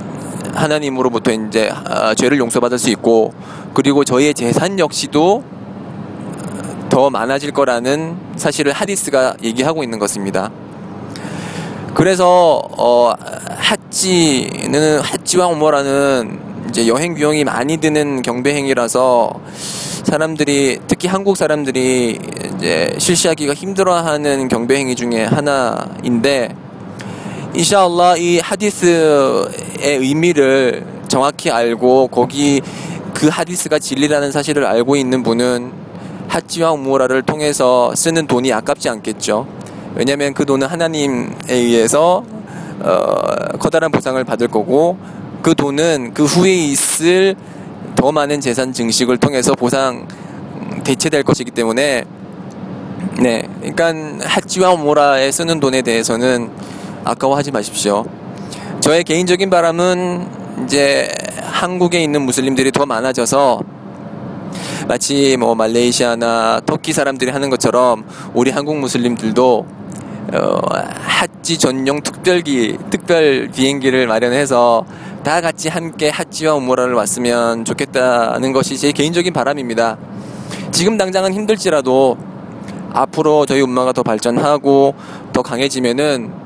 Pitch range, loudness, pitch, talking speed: 125-165 Hz, -14 LUFS, 140 Hz, 275 characters per minute